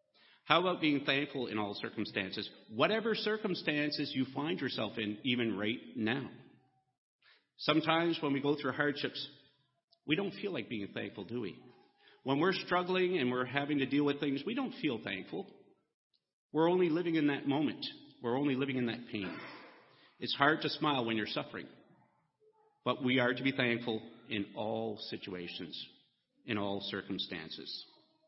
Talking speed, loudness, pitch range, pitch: 160 wpm, -34 LUFS, 115-160 Hz, 140 Hz